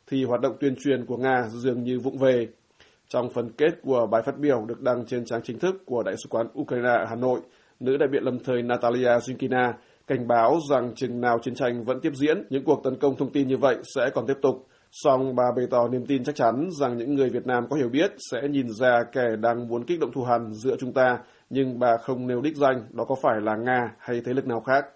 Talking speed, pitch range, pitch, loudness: 255 wpm, 120-135 Hz, 125 Hz, -25 LUFS